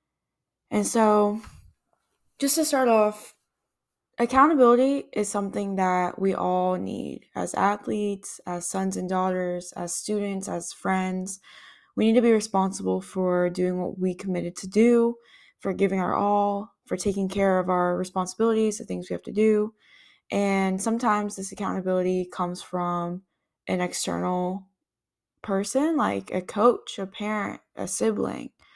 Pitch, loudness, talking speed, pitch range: 195 Hz, -25 LUFS, 140 wpm, 180-215 Hz